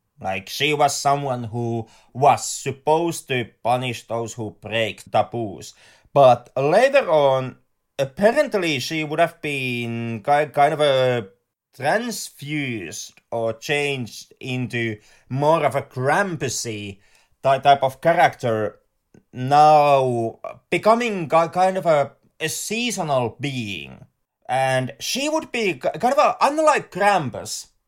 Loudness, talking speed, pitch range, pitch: -21 LUFS, 110 wpm, 115-160 Hz, 135 Hz